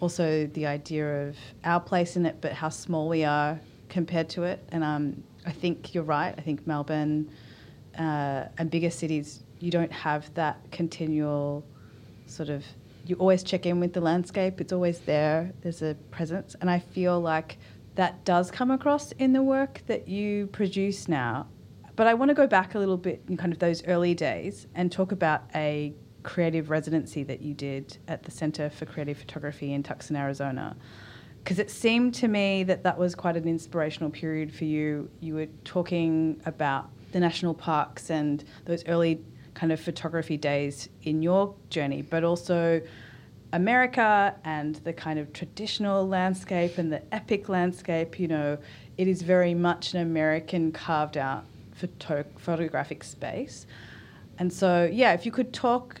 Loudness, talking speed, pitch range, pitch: -28 LUFS, 175 wpm, 150-180 Hz, 160 Hz